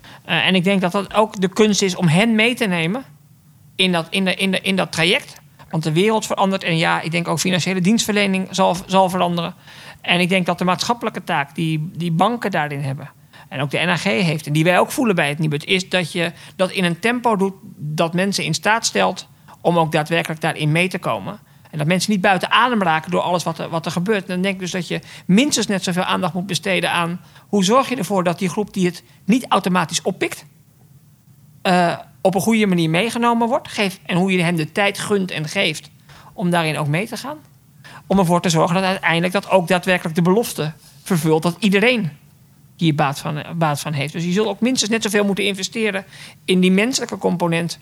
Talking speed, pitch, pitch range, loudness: 225 wpm, 180 Hz, 160-200 Hz, -18 LUFS